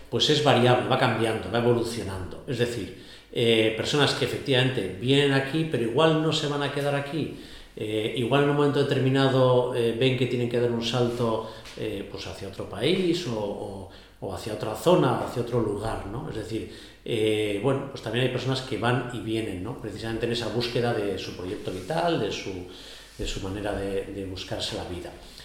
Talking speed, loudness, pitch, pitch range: 200 wpm, -26 LUFS, 115 Hz, 105-130 Hz